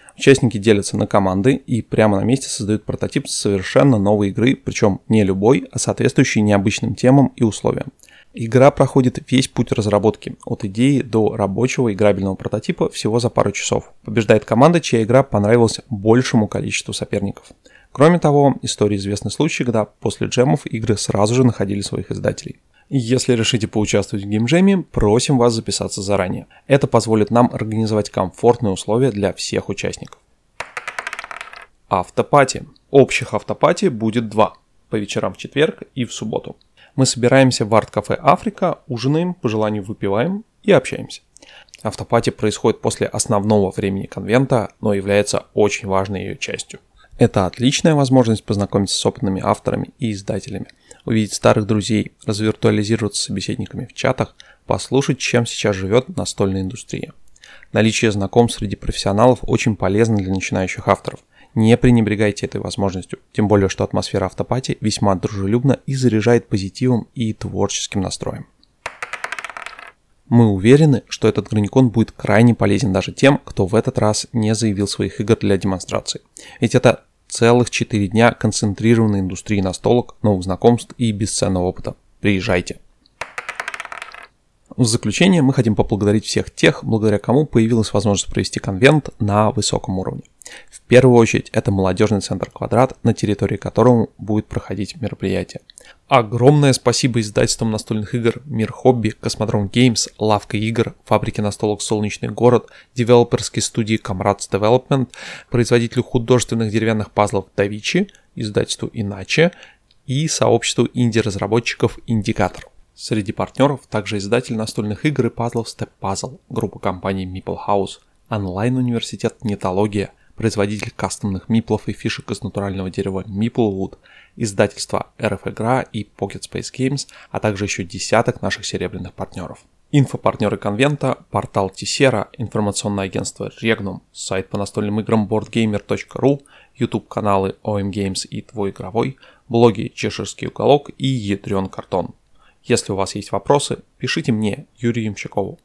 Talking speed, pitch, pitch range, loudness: 135 wpm, 110 Hz, 100-120 Hz, -18 LUFS